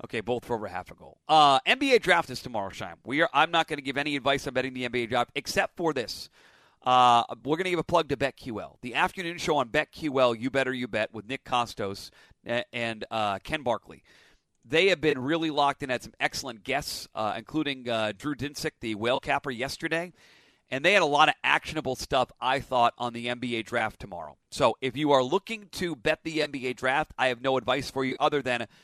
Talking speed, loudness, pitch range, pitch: 225 wpm, -27 LUFS, 120-155 Hz, 130 Hz